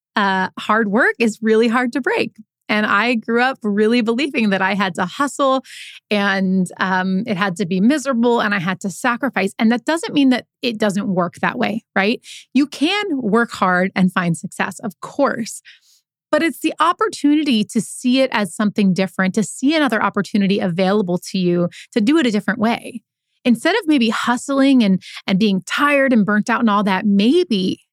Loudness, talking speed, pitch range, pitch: -17 LUFS, 190 wpm, 195-260 Hz, 220 Hz